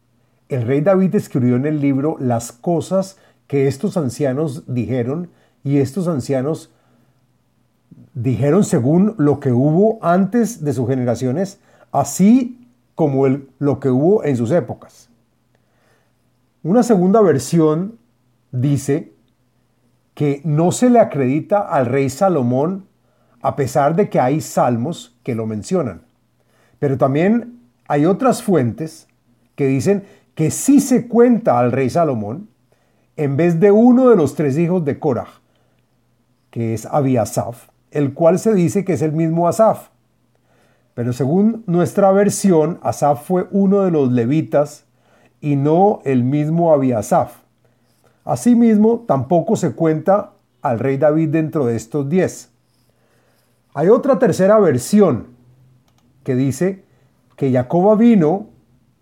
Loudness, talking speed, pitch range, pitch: -16 LUFS, 130 wpm, 125-185 Hz, 145 Hz